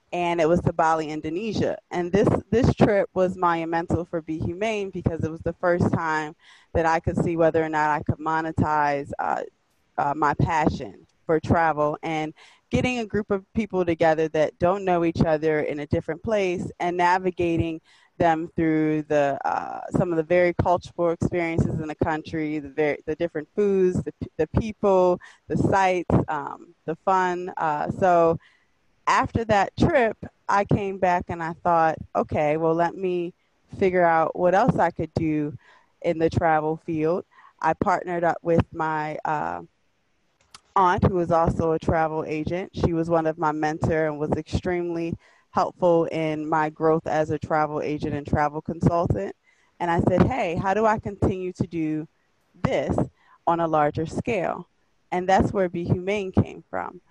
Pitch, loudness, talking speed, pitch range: 165 Hz, -24 LUFS, 170 wpm, 155-180 Hz